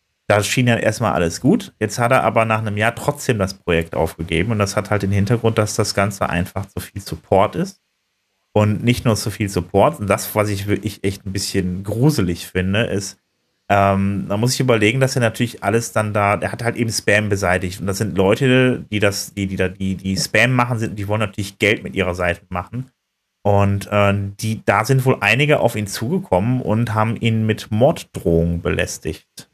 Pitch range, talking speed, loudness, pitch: 95-115 Hz, 210 wpm, -18 LUFS, 105 Hz